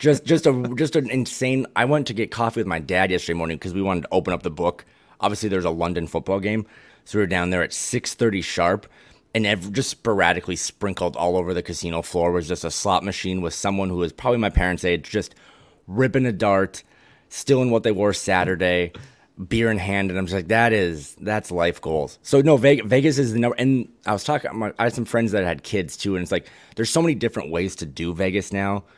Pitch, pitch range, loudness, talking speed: 100 Hz, 90-115 Hz, -22 LUFS, 235 wpm